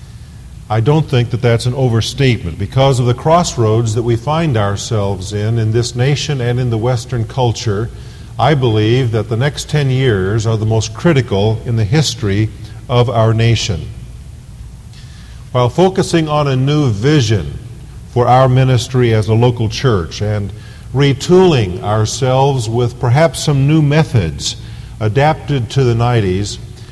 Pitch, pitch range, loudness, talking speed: 120 Hz, 110-135 Hz, -14 LUFS, 145 wpm